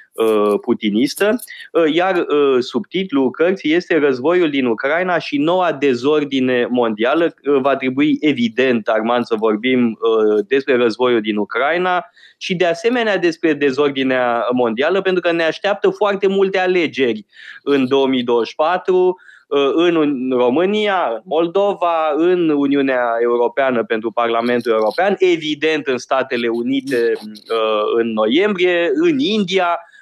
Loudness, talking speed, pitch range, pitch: -16 LUFS, 110 wpm, 120-180 Hz, 140 Hz